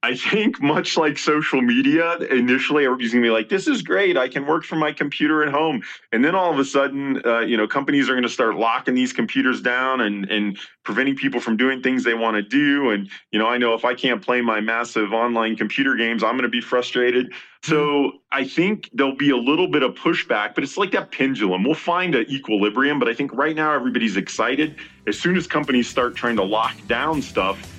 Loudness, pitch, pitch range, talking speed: -20 LUFS, 130 Hz, 115-145 Hz, 225 wpm